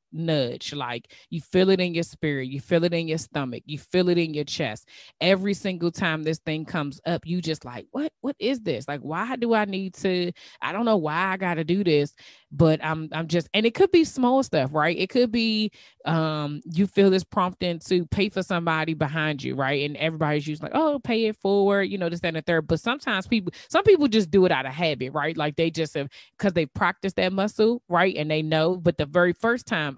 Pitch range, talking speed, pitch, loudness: 155-200 Hz, 240 wpm, 170 Hz, -24 LUFS